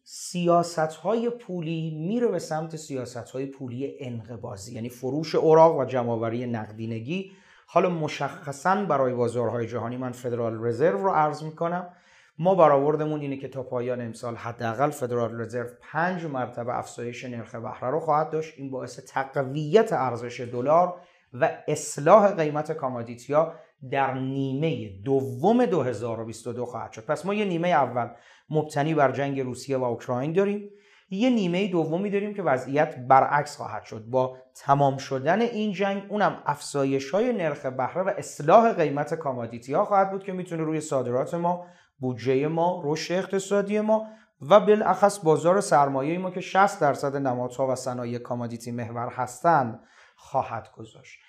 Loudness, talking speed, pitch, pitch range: -25 LUFS, 145 wpm, 145 Hz, 125-175 Hz